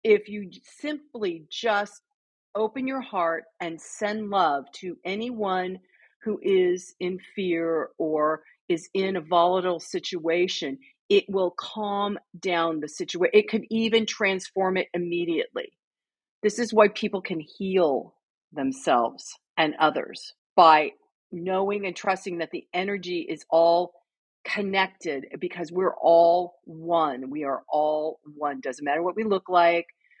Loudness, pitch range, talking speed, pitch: -25 LUFS, 170-205 Hz, 135 wpm, 185 Hz